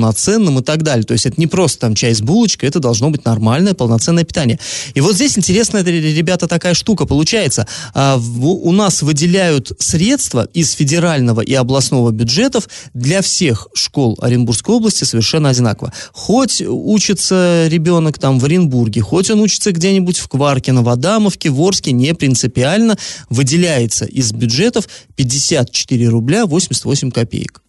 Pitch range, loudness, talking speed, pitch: 125-180 Hz, -13 LUFS, 150 wpm, 150 Hz